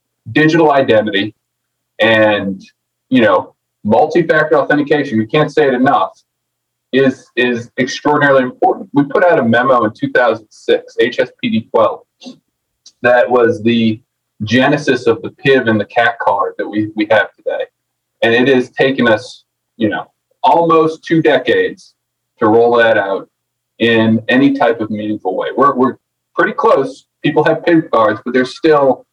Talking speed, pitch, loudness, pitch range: 145 wpm, 135 Hz, -13 LUFS, 110-160 Hz